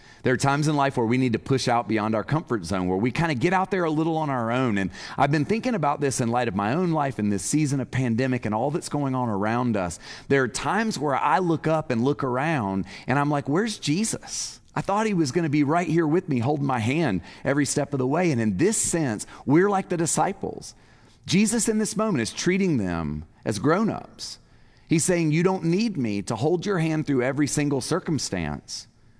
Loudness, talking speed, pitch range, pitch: -24 LUFS, 240 wpm, 120-165 Hz, 140 Hz